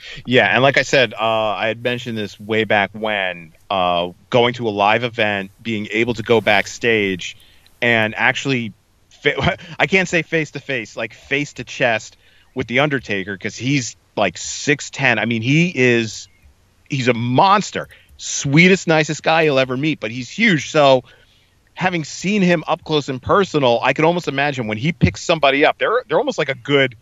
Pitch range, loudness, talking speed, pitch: 105-145 Hz, -17 LUFS, 180 wpm, 120 Hz